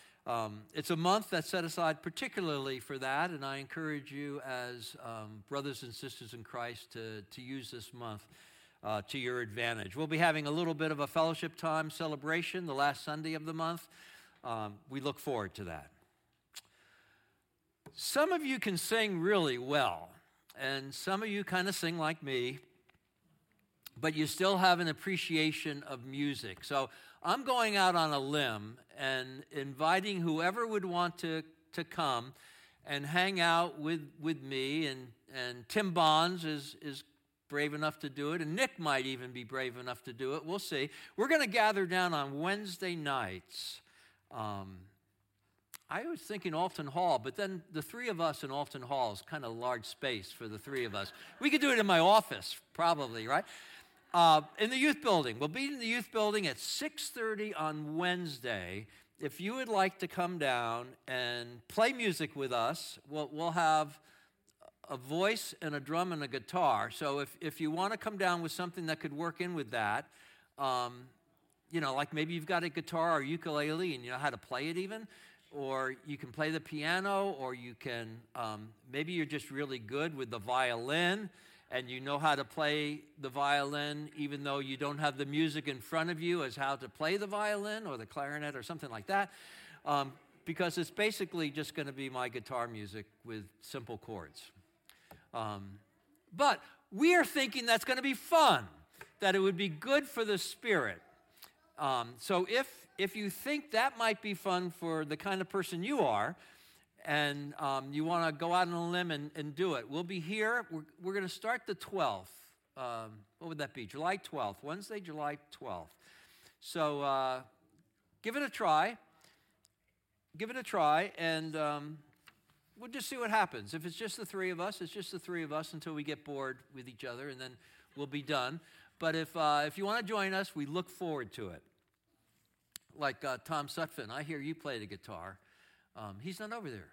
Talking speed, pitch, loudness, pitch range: 195 wpm, 155 Hz, -35 LUFS, 135-180 Hz